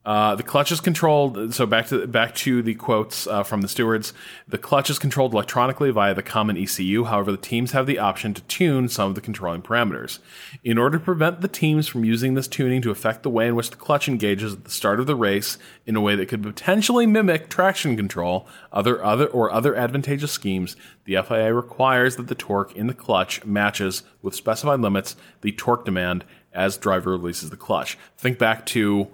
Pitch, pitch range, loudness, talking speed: 115 Hz, 100-135 Hz, -22 LUFS, 210 wpm